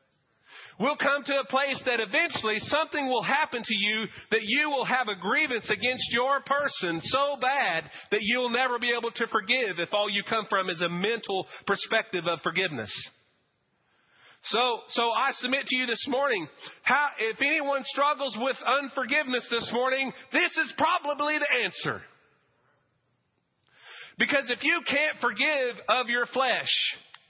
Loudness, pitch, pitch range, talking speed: -26 LUFS, 250 Hz, 220-280 Hz, 155 wpm